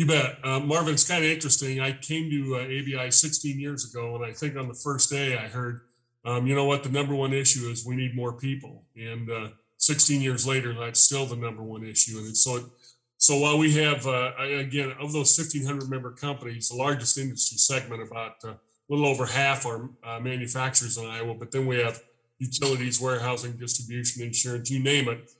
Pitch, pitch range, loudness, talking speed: 130 Hz, 120-140 Hz, -22 LUFS, 210 wpm